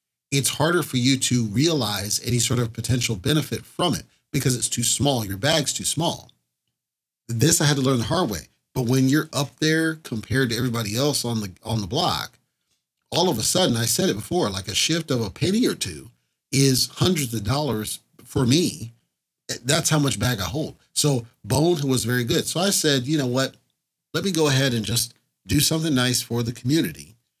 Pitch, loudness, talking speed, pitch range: 130 Hz, -22 LUFS, 205 wpm, 115-150 Hz